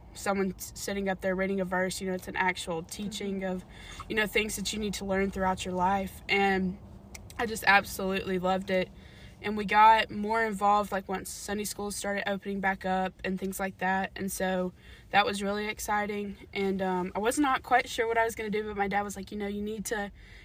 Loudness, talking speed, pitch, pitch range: -29 LUFS, 225 wpm, 195 Hz, 185-210 Hz